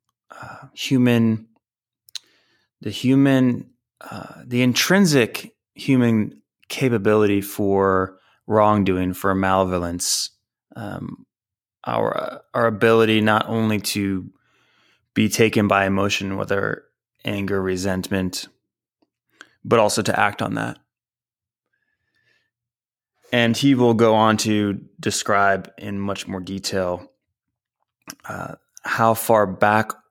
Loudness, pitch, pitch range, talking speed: -20 LUFS, 105 Hz, 95-115 Hz, 100 wpm